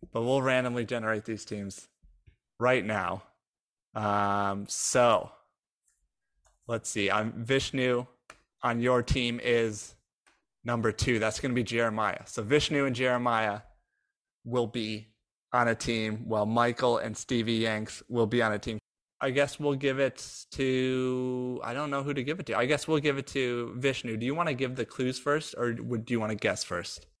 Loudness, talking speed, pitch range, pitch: -29 LUFS, 180 wpm, 110-130 Hz, 120 Hz